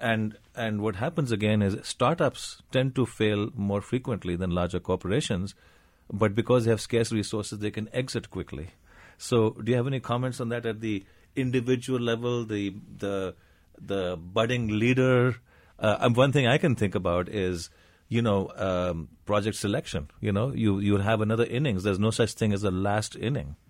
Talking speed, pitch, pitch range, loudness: 175 wpm, 105 Hz, 95-120 Hz, -27 LUFS